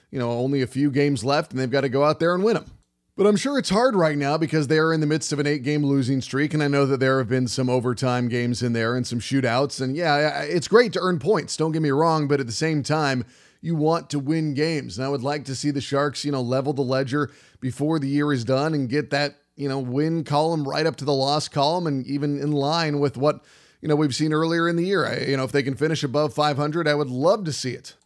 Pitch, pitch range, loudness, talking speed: 145 Hz, 135-155 Hz, -23 LUFS, 280 wpm